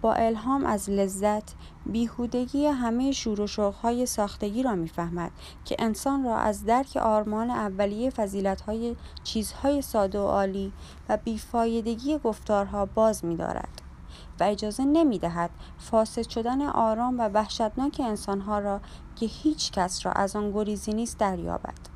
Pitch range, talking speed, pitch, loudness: 205-240 Hz, 130 wpm, 220 Hz, -27 LUFS